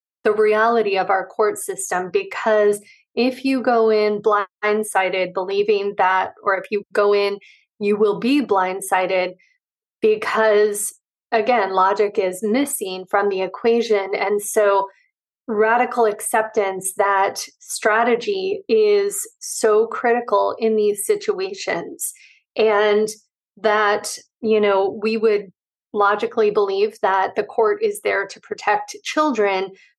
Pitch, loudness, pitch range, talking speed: 215 Hz, -19 LUFS, 200-265 Hz, 120 wpm